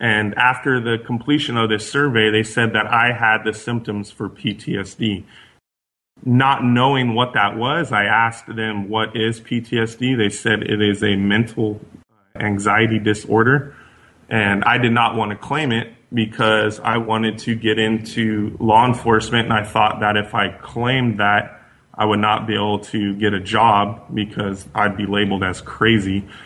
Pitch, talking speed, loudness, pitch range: 110 Hz, 170 wpm, -18 LUFS, 105-120 Hz